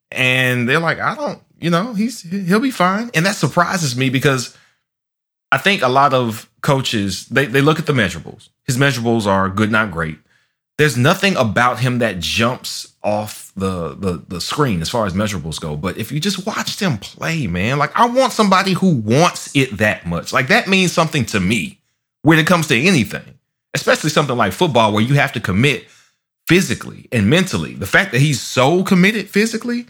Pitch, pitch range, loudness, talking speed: 140 Hz, 110-180 Hz, -16 LUFS, 195 wpm